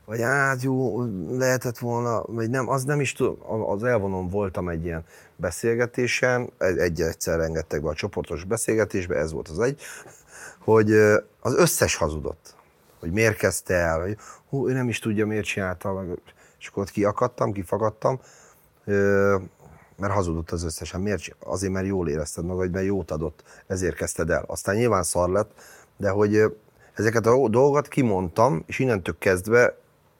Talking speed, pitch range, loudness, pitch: 150 wpm, 90-120 Hz, -24 LUFS, 105 Hz